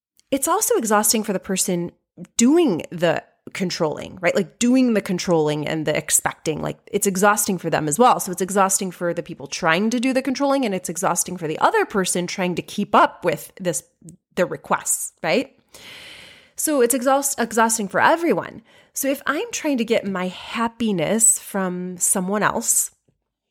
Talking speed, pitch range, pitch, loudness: 175 wpm, 175-240 Hz, 195 Hz, -20 LUFS